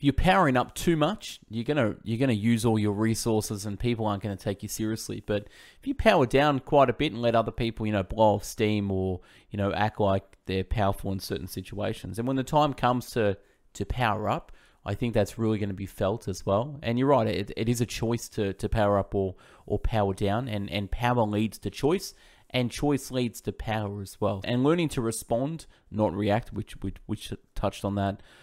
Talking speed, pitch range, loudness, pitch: 225 wpm, 100-120 Hz, -28 LUFS, 110 Hz